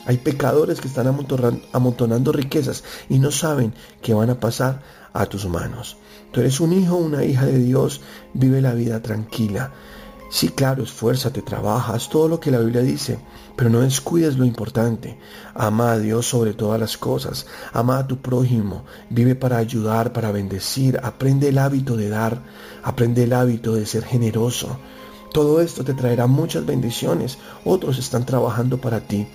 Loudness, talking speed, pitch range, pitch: -20 LUFS, 170 wpm, 115-135 Hz, 125 Hz